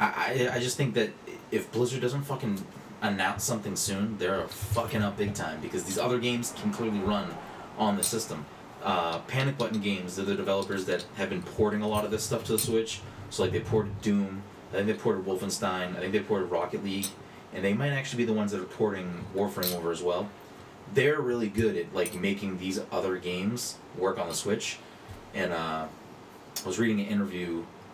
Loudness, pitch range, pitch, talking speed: -30 LUFS, 95-115 Hz, 105 Hz, 205 wpm